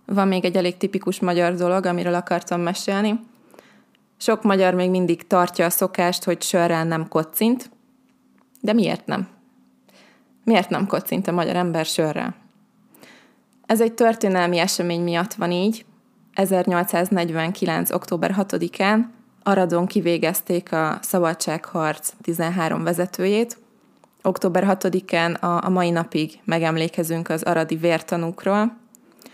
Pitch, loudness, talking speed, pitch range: 180 Hz, -21 LUFS, 115 wpm, 170-210 Hz